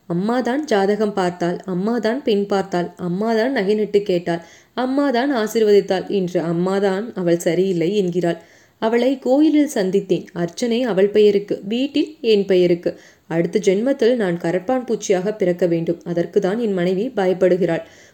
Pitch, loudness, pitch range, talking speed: 200 Hz, -19 LUFS, 180-225 Hz, 120 wpm